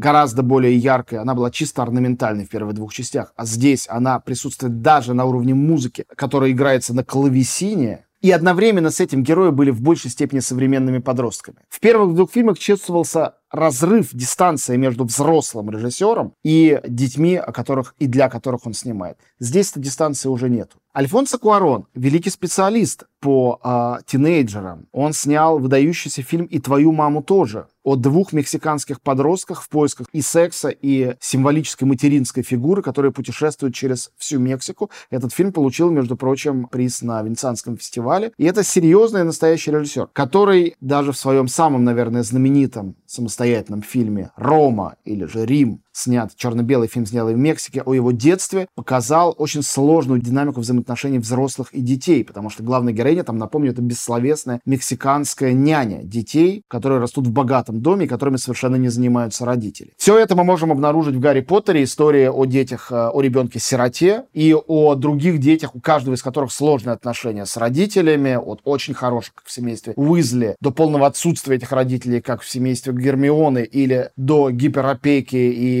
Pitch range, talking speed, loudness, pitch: 125-155 Hz, 160 wpm, -18 LUFS, 135 Hz